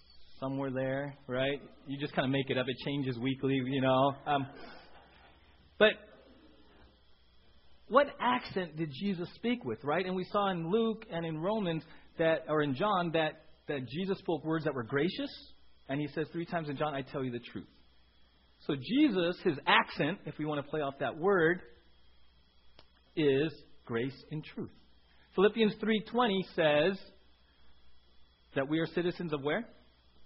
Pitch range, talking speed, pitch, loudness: 105-170 Hz, 160 wpm, 145 Hz, -33 LUFS